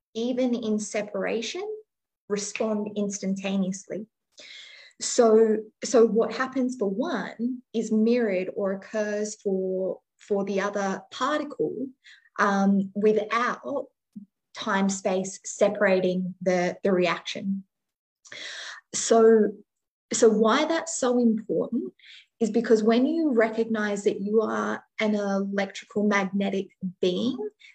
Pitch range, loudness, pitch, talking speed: 195-230 Hz, -25 LUFS, 210 Hz, 100 wpm